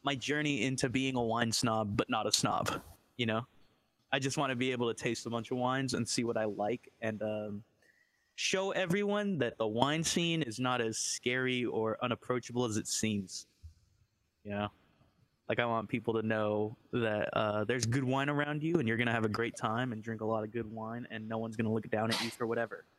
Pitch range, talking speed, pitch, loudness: 110-130 Hz, 225 wpm, 115 Hz, -34 LUFS